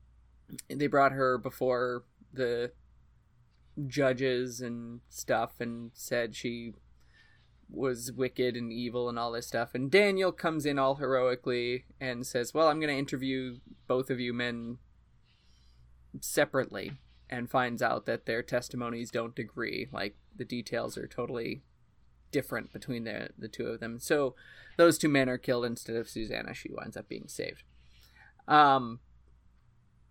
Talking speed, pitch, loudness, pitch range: 145 wpm, 120 Hz, -31 LUFS, 115-130 Hz